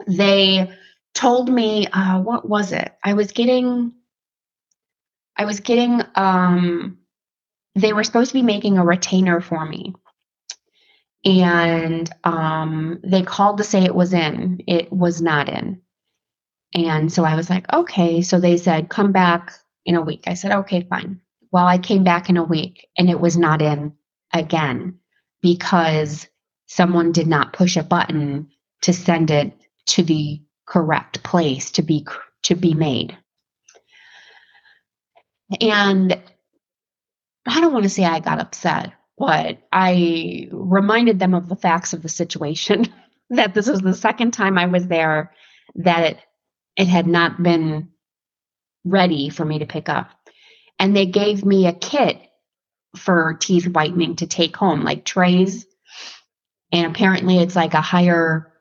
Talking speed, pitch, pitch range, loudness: 150 wpm, 180 Hz, 165-200 Hz, -18 LUFS